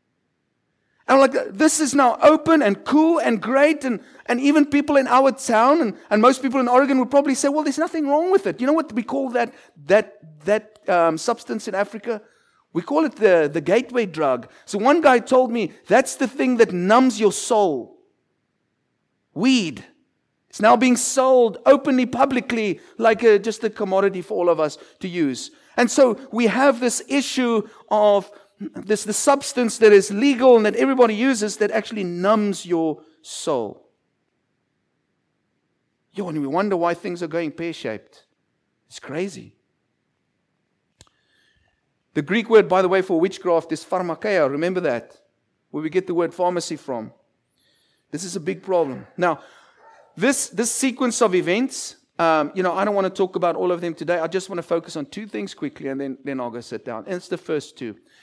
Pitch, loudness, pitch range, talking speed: 220 Hz, -20 LUFS, 180-265 Hz, 180 wpm